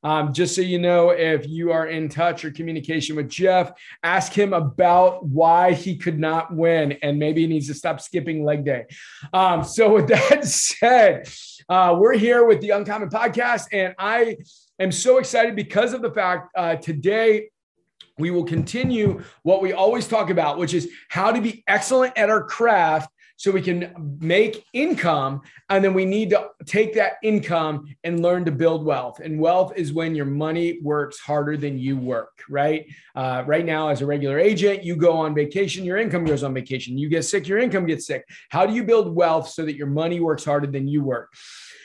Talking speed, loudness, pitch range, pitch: 200 wpm, -20 LUFS, 155-200 Hz, 170 Hz